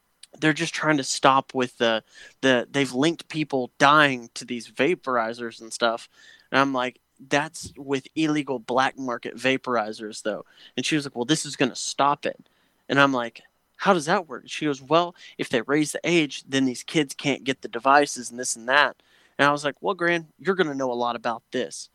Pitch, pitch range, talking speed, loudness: 135 Hz, 120-150 Hz, 210 wpm, -24 LUFS